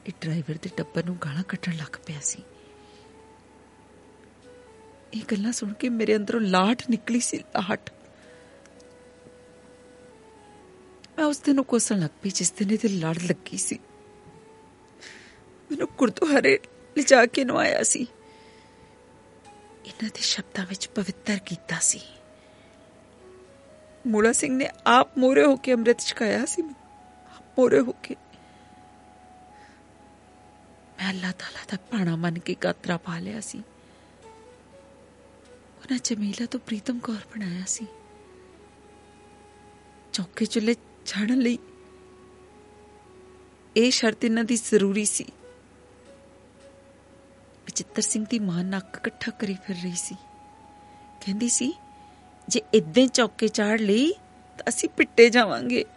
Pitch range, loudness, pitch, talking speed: 175-245 Hz, -24 LUFS, 215 Hz, 120 wpm